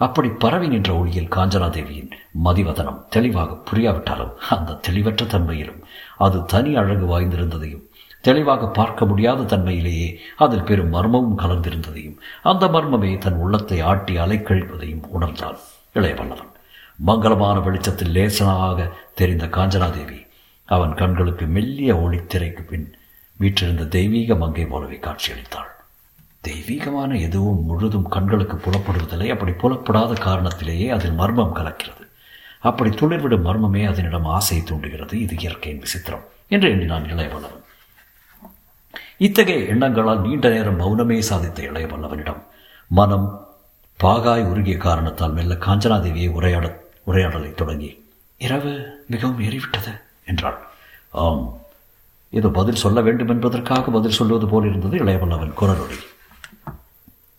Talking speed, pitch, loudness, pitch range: 105 wpm, 95 Hz, -20 LUFS, 85-110 Hz